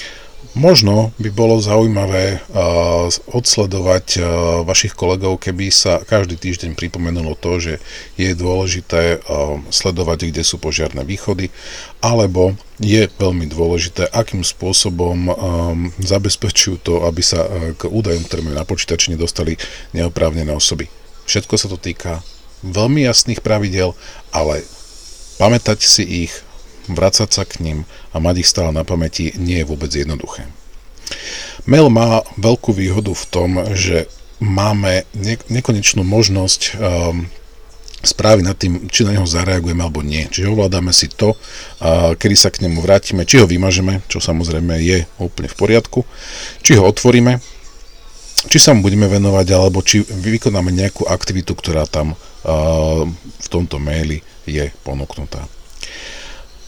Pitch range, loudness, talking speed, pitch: 85-105 Hz, -15 LUFS, 135 wpm, 90 Hz